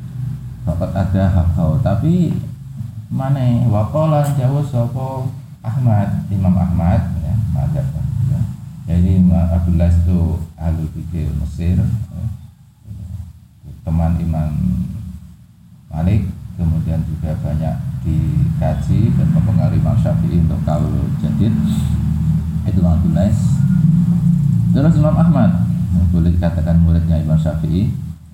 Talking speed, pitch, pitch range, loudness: 105 wpm, 95 Hz, 85-130 Hz, -16 LUFS